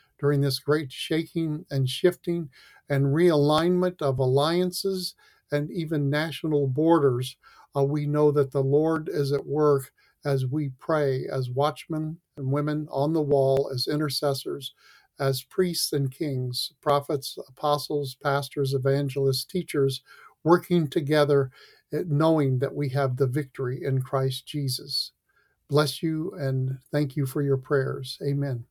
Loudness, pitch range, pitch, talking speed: -26 LUFS, 135-155 Hz, 145 Hz, 135 wpm